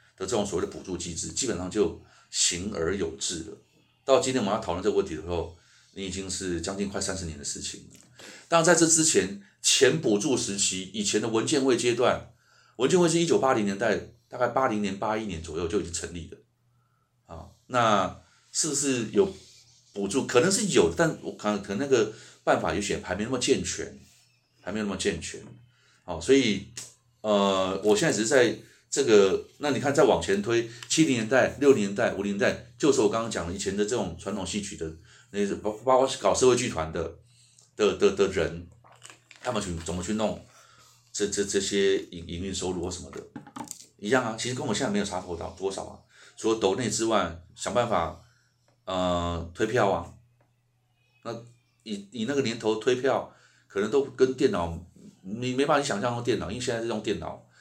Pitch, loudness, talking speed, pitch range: 110 Hz, -26 LUFS, 285 characters per minute, 95-125 Hz